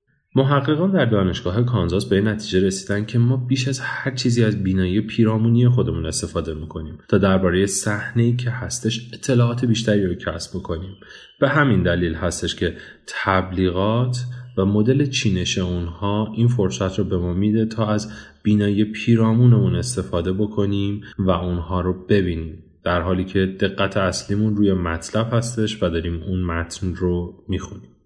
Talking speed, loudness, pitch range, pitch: 150 wpm, -20 LUFS, 90-115 Hz, 100 Hz